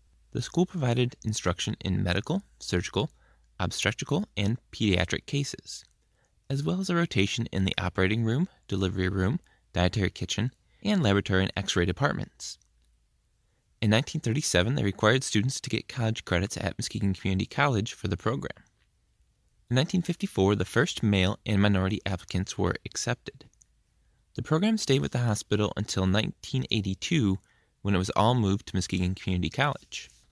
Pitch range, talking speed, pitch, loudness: 95-120 Hz, 145 wpm, 100 Hz, -28 LUFS